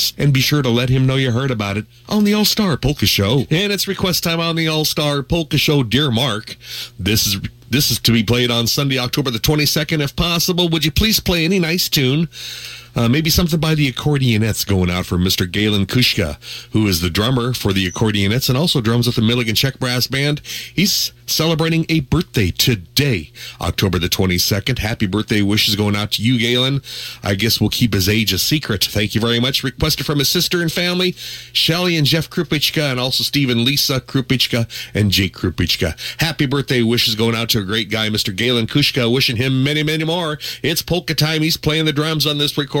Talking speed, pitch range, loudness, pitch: 210 wpm, 110-155 Hz, -16 LUFS, 125 Hz